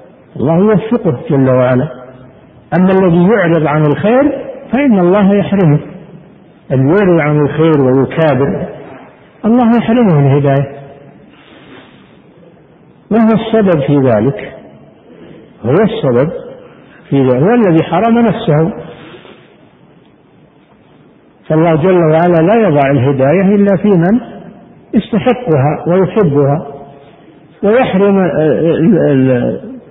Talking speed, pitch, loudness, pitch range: 90 wpm, 165 Hz, -10 LUFS, 140-205 Hz